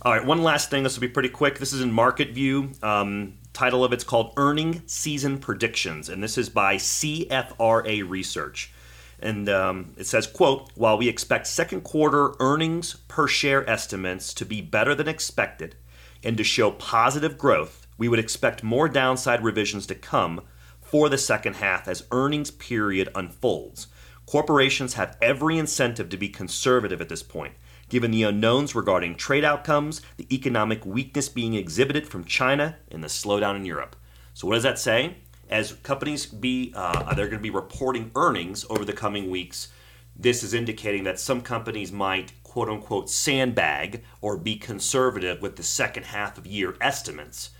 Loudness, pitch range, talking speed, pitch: -24 LUFS, 95-135 Hz, 170 wpm, 115 Hz